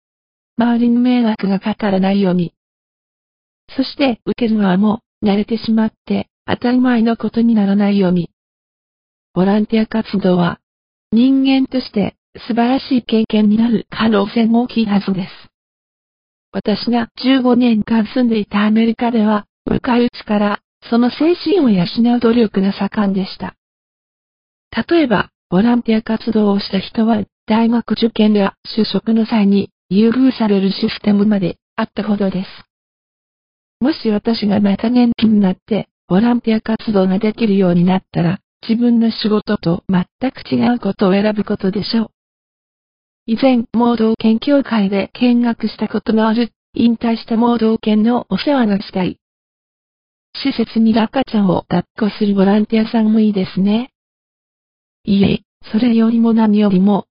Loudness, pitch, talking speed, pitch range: -15 LUFS, 220 Hz, 300 characters per minute, 200-235 Hz